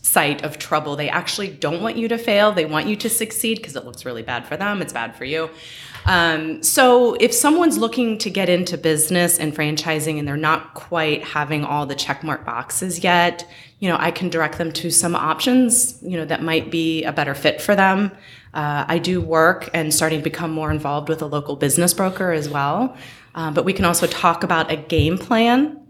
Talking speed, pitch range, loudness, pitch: 215 wpm, 150-185 Hz, -19 LUFS, 165 Hz